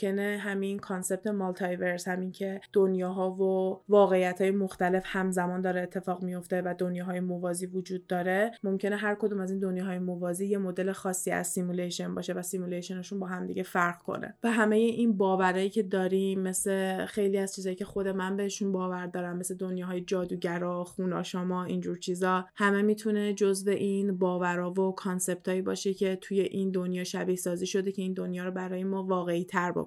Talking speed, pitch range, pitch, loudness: 175 wpm, 180-195 Hz, 185 Hz, -30 LUFS